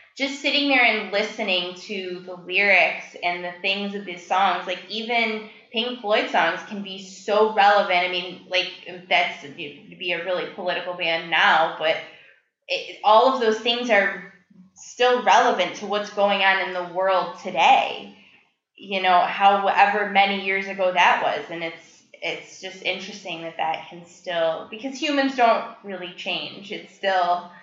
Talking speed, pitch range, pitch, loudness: 160 wpm, 180-210 Hz, 190 Hz, -21 LUFS